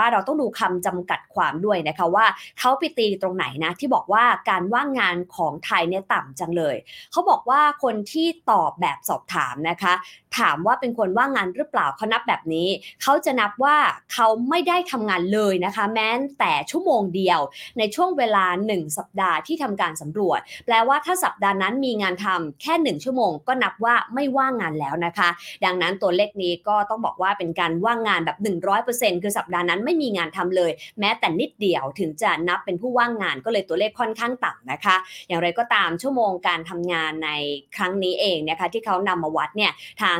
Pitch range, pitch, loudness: 175-245 Hz, 205 Hz, -22 LUFS